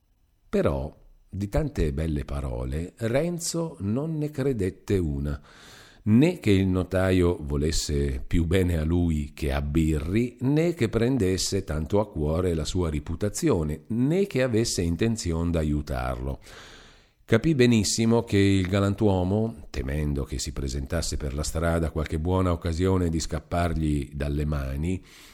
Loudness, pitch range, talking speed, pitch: -26 LUFS, 75-105 Hz, 130 wpm, 85 Hz